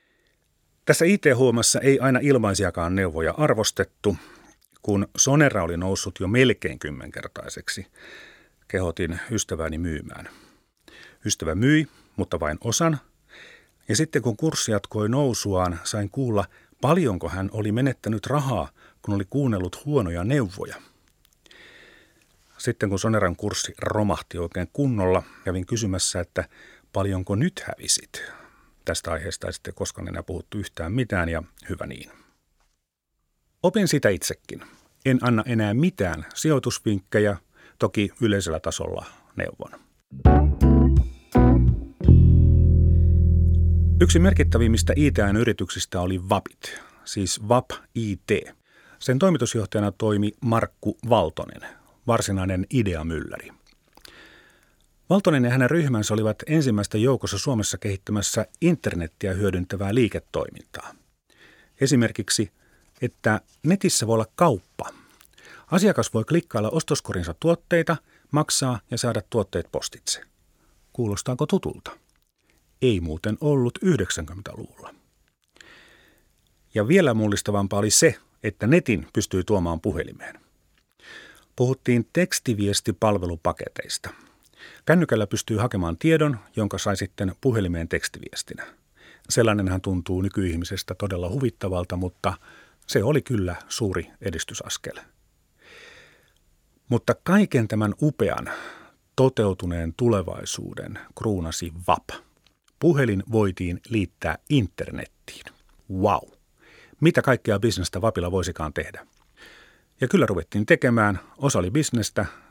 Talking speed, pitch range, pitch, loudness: 100 wpm, 90-125 Hz, 105 Hz, -23 LUFS